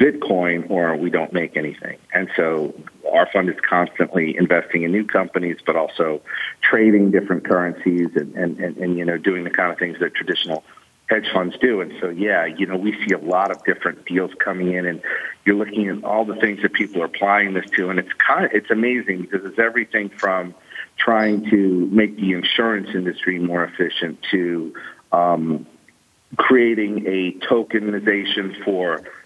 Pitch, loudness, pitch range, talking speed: 95 Hz, -19 LUFS, 90-105 Hz, 180 wpm